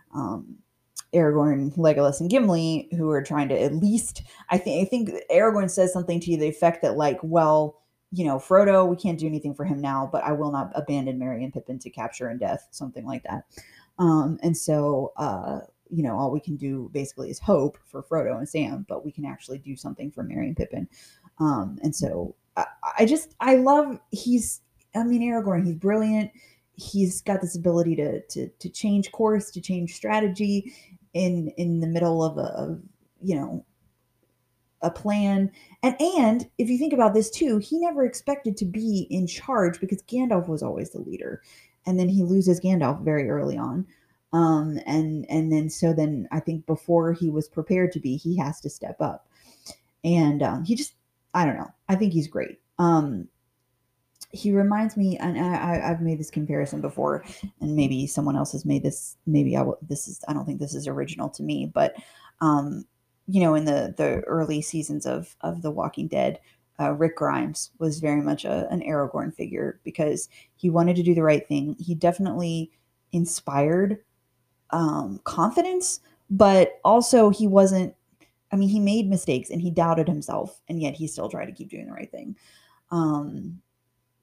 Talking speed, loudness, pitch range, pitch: 185 wpm, -24 LUFS, 150-195 Hz, 170 Hz